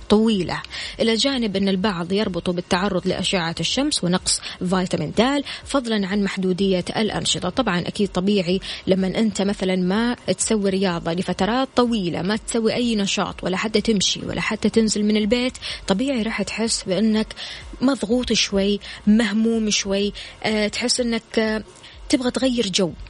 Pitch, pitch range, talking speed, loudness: 205 Hz, 185-225 Hz, 135 wpm, -21 LUFS